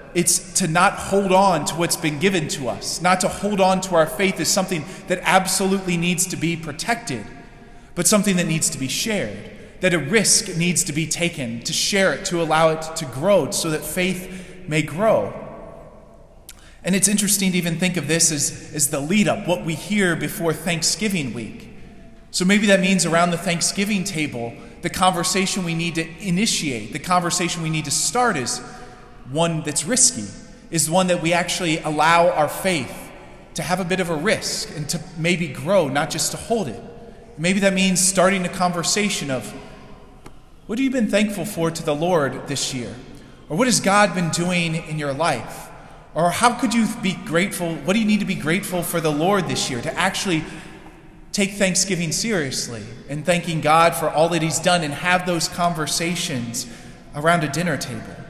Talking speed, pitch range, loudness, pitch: 190 wpm, 160-190 Hz, -20 LUFS, 175 Hz